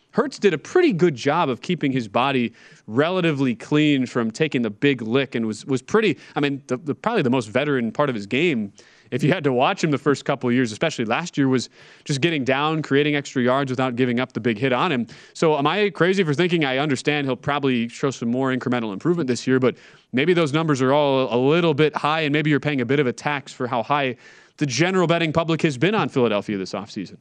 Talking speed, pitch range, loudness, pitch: 245 wpm, 125-155 Hz, -21 LUFS, 140 Hz